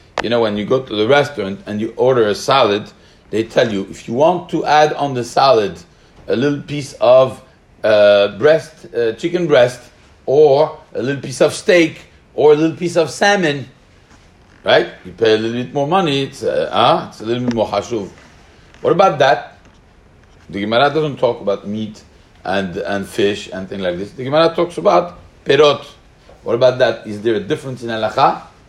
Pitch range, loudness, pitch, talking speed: 105-155 Hz, -15 LUFS, 130 Hz, 190 wpm